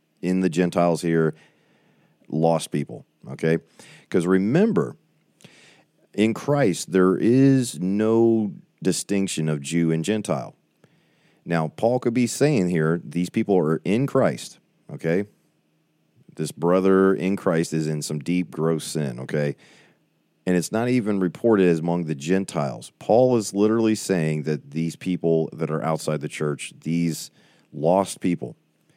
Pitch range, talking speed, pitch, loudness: 80-100 Hz, 135 wpm, 85 Hz, -23 LUFS